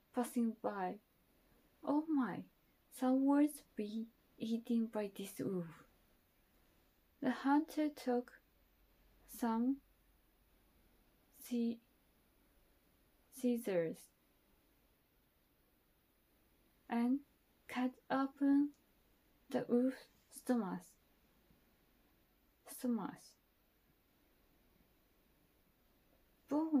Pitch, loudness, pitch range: 245 Hz, -39 LUFS, 225-275 Hz